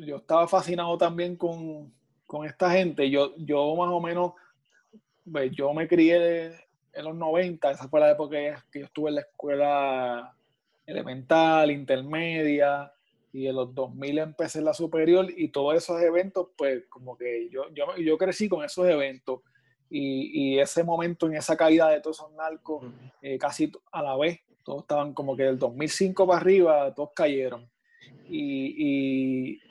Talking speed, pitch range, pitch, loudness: 170 wpm, 140-170 Hz, 155 Hz, -26 LUFS